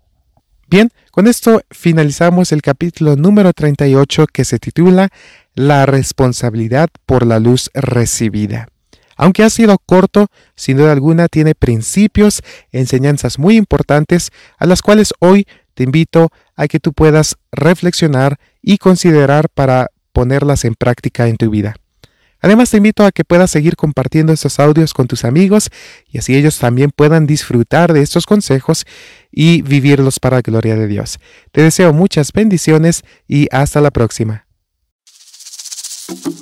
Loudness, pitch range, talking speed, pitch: -11 LUFS, 130-175 Hz, 140 wpm, 150 Hz